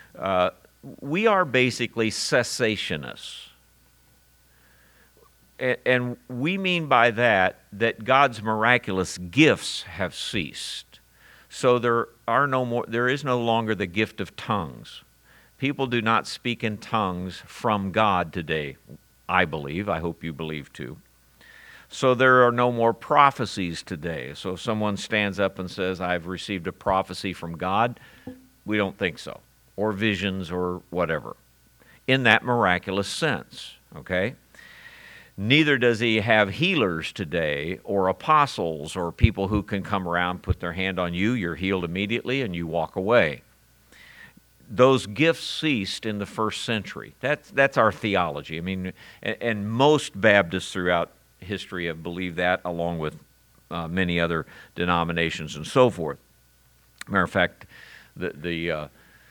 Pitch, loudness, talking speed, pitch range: 100 Hz, -24 LUFS, 145 wpm, 85-120 Hz